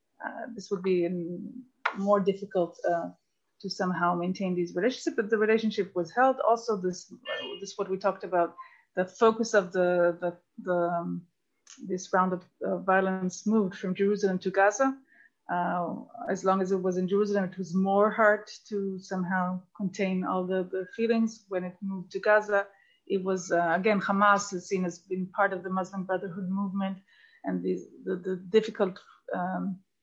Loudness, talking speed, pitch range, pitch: -29 LUFS, 175 wpm, 180-210 Hz, 190 Hz